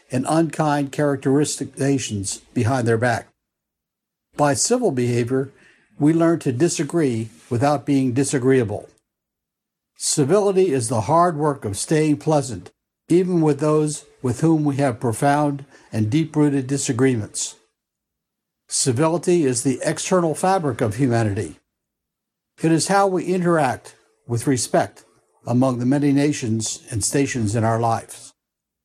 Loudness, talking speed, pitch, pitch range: -20 LUFS, 125 wpm, 140 Hz, 120-155 Hz